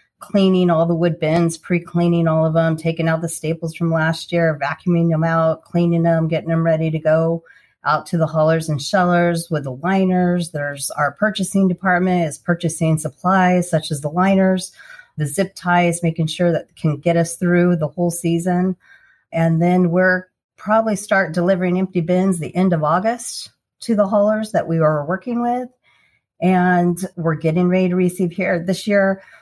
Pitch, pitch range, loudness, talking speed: 175 Hz, 165-185 Hz, -18 LUFS, 180 wpm